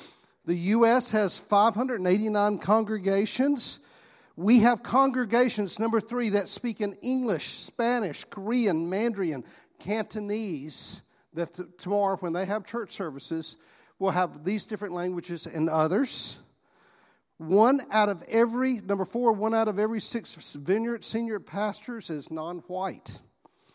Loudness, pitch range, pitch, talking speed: -27 LUFS, 180-230 Hz, 205 Hz, 125 wpm